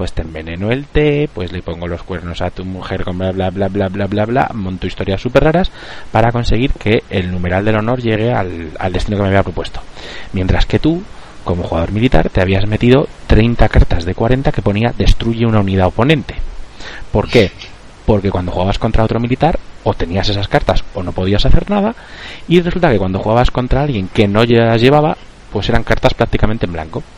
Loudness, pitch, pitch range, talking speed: -15 LUFS, 105 Hz, 95-120 Hz, 205 wpm